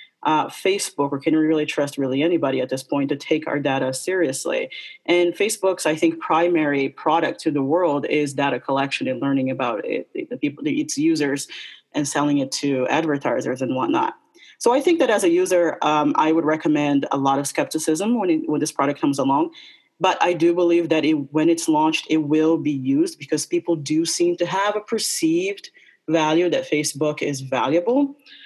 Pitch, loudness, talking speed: 160 Hz, -21 LUFS, 195 wpm